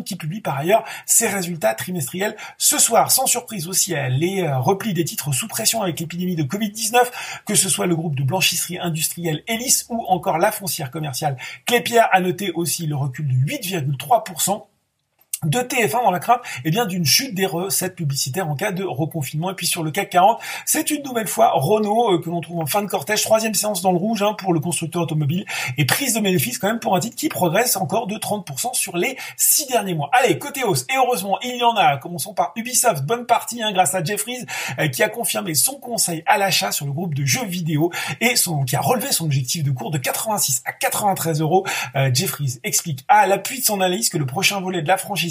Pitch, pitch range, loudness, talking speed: 185 Hz, 160-220 Hz, -19 LUFS, 225 wpm